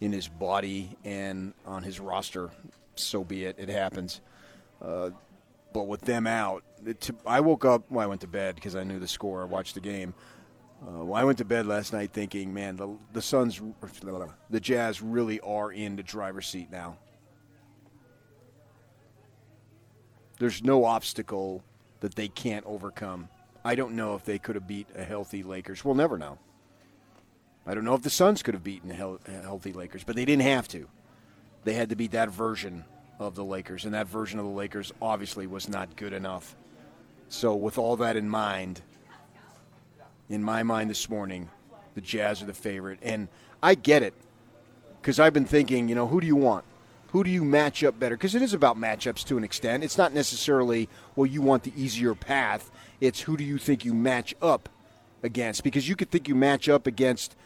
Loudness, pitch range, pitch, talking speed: -28 LUFS, 100-125 Hz, 110 Hz, 195 wpm